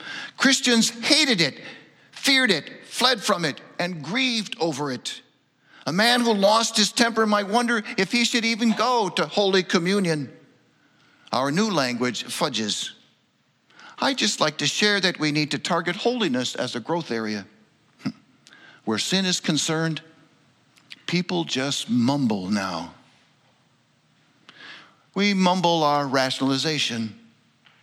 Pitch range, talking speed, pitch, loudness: 140-220 Hz, 125 wpm, 175 Hz, -22 LUFS